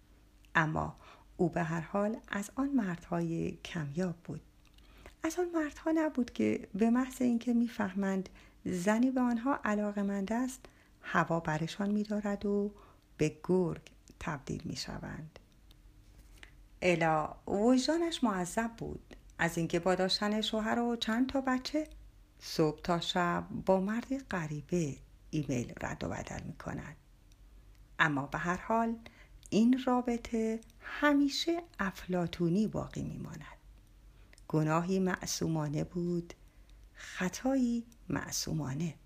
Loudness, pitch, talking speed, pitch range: -33 LUFS, 195 Hz, 115 wpm, 165-235 Hz